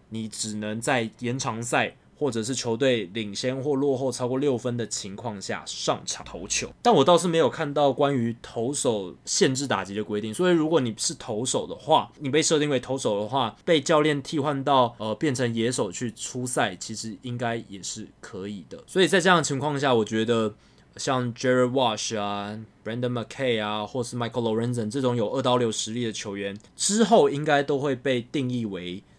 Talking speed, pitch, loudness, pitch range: 335 characters per minute, 125 Hz, -25 LUFS, 110-140 Hz